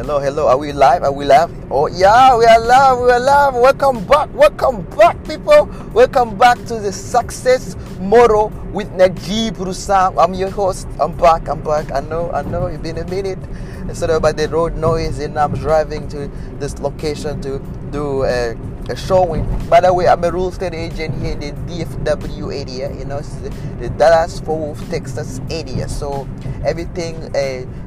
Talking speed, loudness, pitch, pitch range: 185 wpm, -15 LUFS, 160 Hz, 140-190 Hz